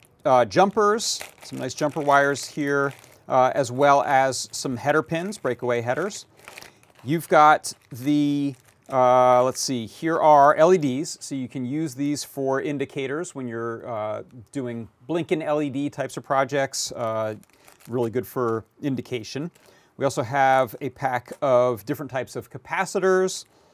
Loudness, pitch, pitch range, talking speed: -23 LUFS, 135 Hz, 125-150 Hz, 140 wpm